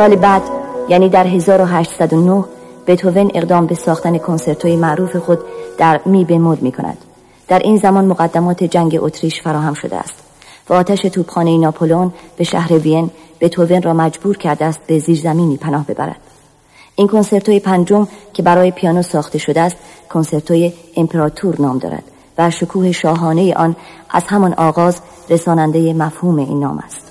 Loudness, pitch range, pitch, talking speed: -13 LUFS, 160-180 Hz, 170 Hz, 150 wpm